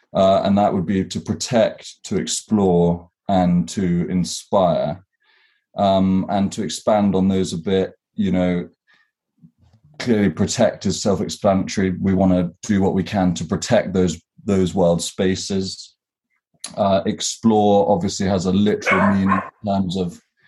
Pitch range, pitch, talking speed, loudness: 90-100 Hz, 95 Hz, 145 wpm, -19 LUFS